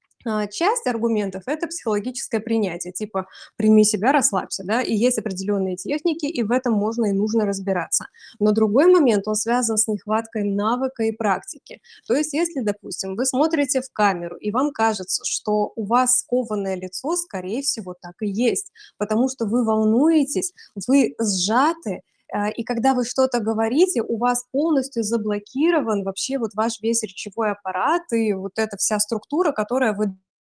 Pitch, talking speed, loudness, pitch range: 225 Hz, 160 wpm, -22 LUFS, 210-260 Hz